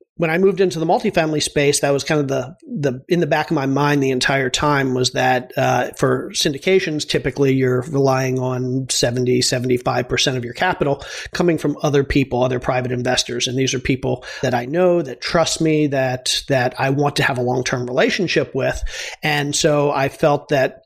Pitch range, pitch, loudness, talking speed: 130-155 Hz, 140 Hz, -18 LUFS, 200 wpm